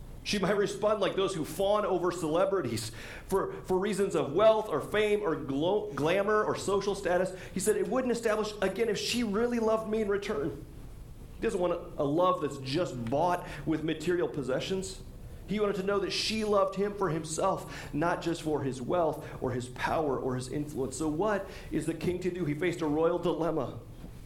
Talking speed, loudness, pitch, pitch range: 200 wpm, -30 LUFS, 180 Hz, 150-200 Hz